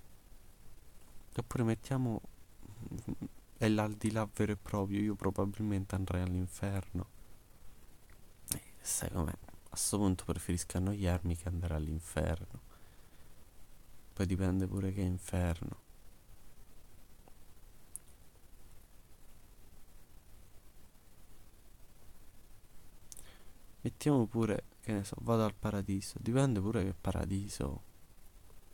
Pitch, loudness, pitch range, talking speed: 95 Hz, -36 LUFS, 90-105 Hz, 90 wpm